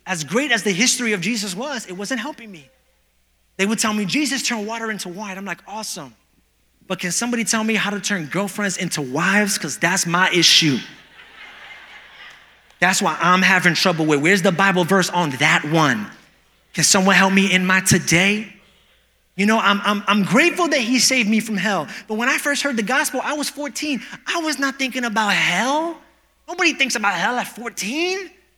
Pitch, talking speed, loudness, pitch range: 205 Hz, 195 wpm, -18 LUFS, 185-250 Hz